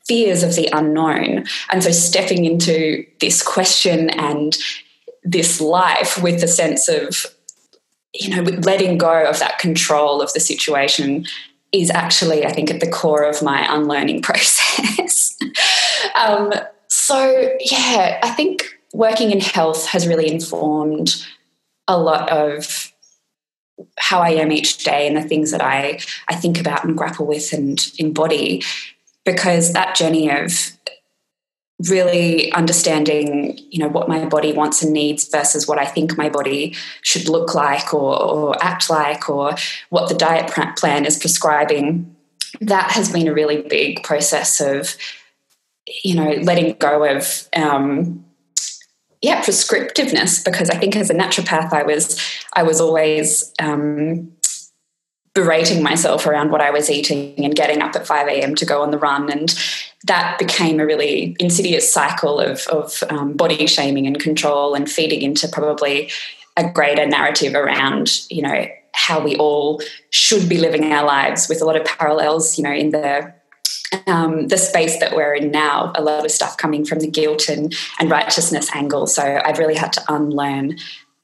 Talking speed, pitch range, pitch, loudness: 160 wpm, 150-170 Hz, 155 Hz, -16 LUFS